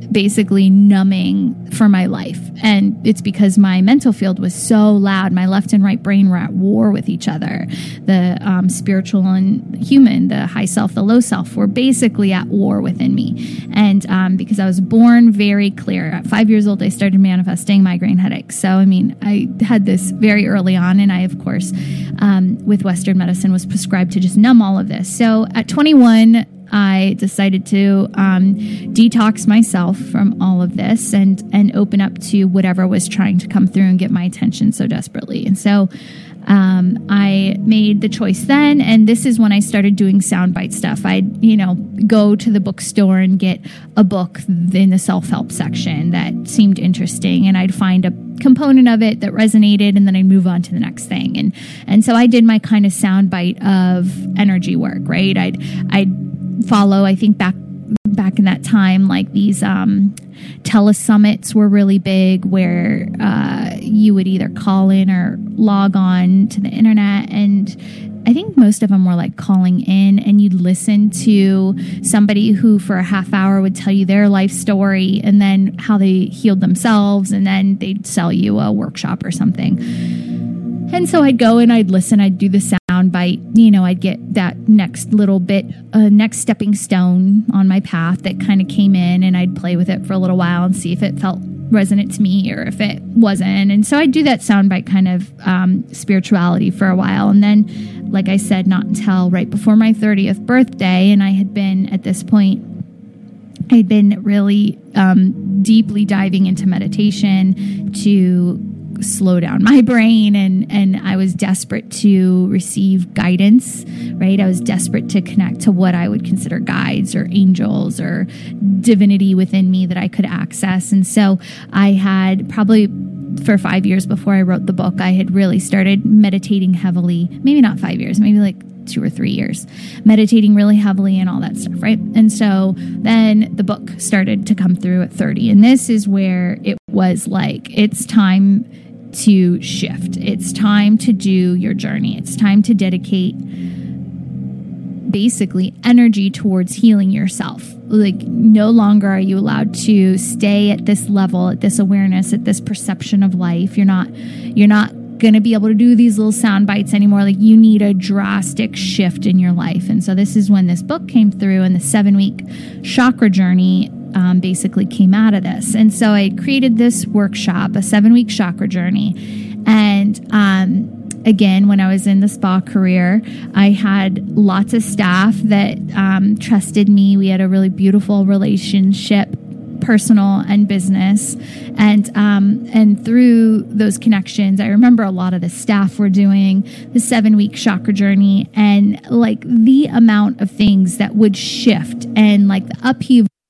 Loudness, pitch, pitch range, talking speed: -13 LUFS, 200 Hz, 190-215 Hz, 185 wpm